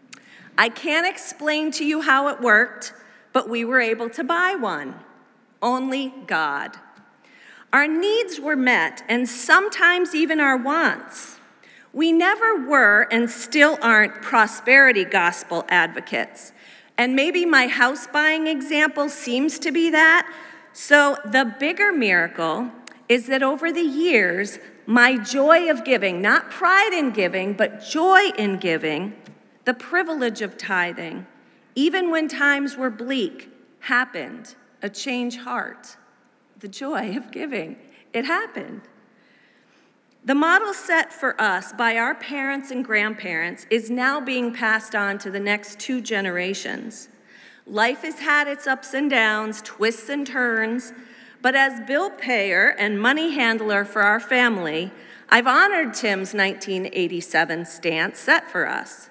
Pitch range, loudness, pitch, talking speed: 220-305 Hz, -20 LUFS, 255 Hz, 135 wpm